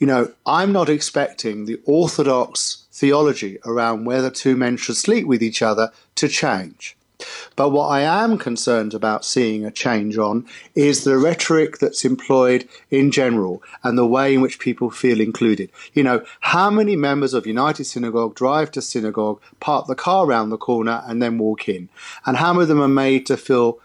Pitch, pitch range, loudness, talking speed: 125 Hz, 115-140 Hz, -19 LUFS, 185 wpm